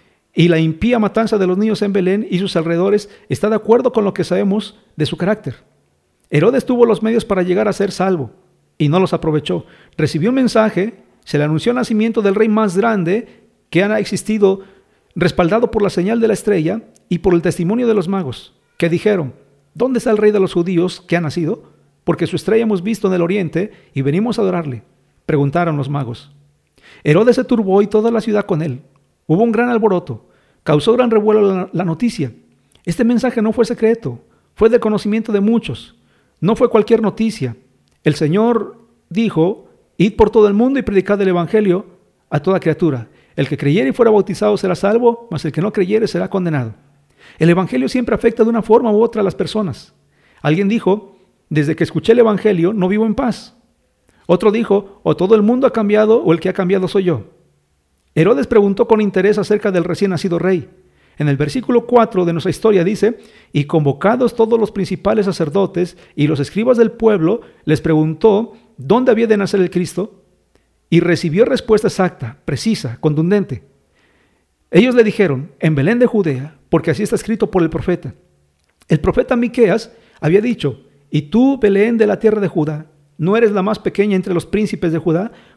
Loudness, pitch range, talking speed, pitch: -15 LUFS, 165-220 Hz, 190 wpm, 195 Hz